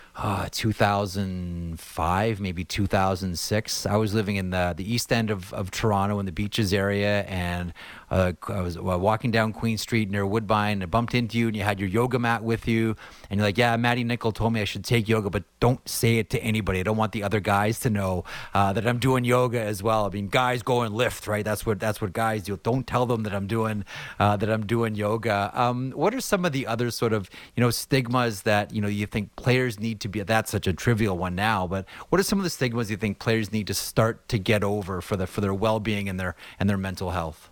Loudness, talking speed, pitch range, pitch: -25 LUFS, 245 wpm, 100-115 Hz, 110 Hz